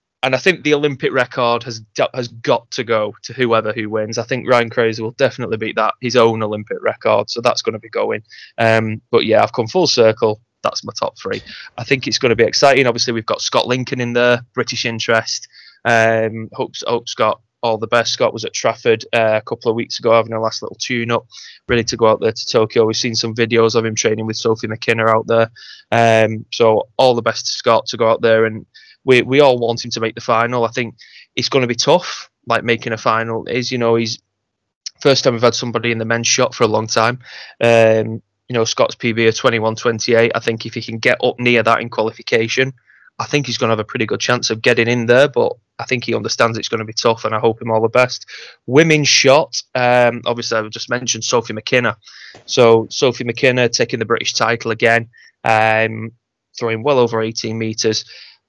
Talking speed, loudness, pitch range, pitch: 230 wpm, -16 LUFS, 110-120 Hz, 115 Hz